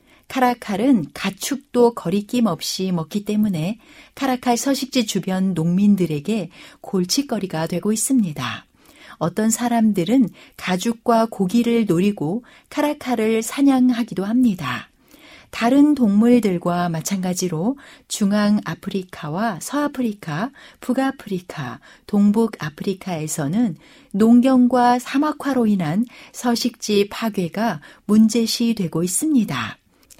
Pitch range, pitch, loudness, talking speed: 185-245 Hz, 220 Hz, -20 LUFS, 255 characters per minute